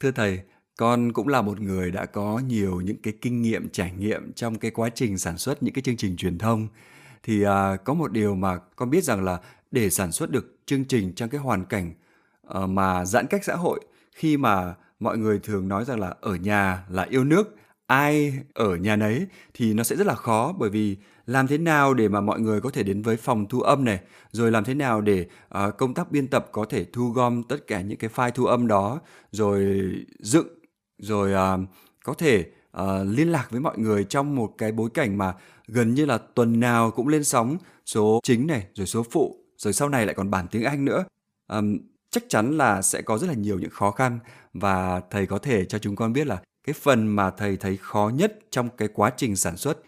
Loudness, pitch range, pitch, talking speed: -24 LUFS, 100-125 Hz, 110 Hz, 230 wpm